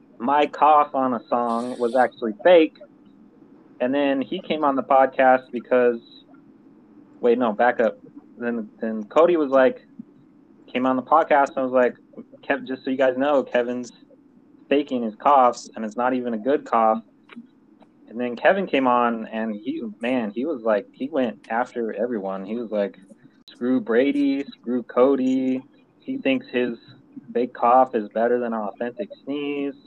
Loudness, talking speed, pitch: -22 LUFS, 165 wpm, 135 Hz